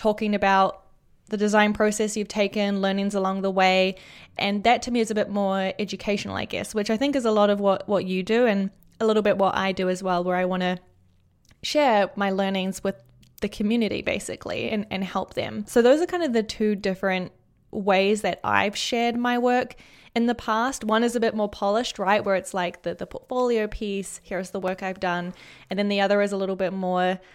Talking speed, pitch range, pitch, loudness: 225 wpm, 190-220 Hz, 200 Hz, -24 LUFS